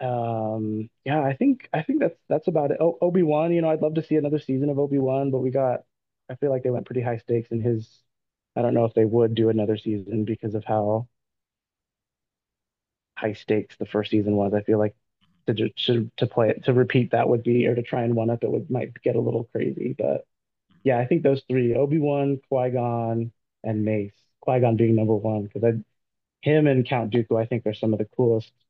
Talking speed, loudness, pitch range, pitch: 230 wpm, -24 LUFS, 110-130 Hz, 120 Hz